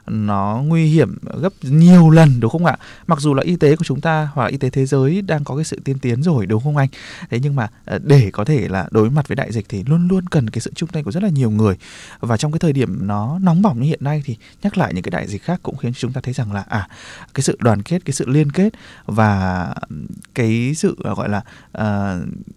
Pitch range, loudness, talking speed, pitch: 110-160 Hz, -17 LUFS, 260 wpm, 135 Hz